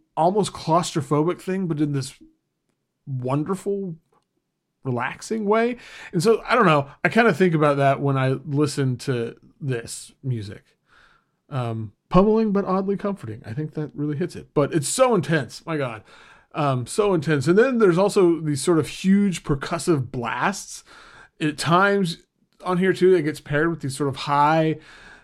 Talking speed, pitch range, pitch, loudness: 165 wpm, 140-185 Hz, 155 Hz, -22 LUFS